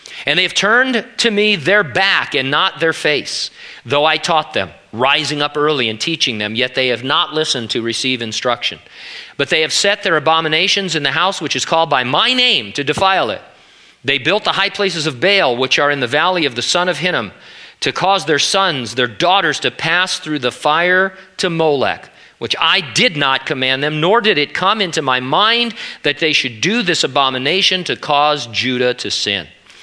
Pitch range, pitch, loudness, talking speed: 130-185 Hz, 155 Hz, -14 LUFS, 205 wpm